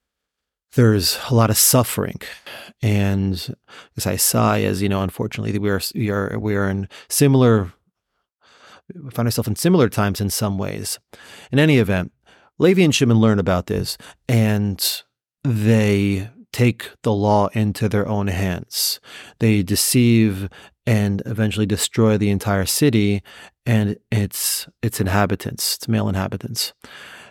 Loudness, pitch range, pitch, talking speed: -19 LUFS, 100-115 Hz, 105 Hz, 140 wpm